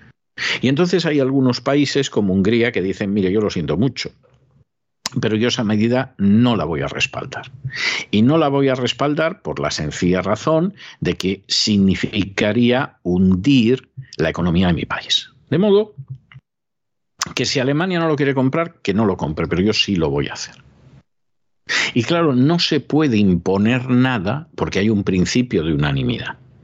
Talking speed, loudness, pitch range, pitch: 170 wpm, -18 LUFS, 100-140 Hz, 125 Hz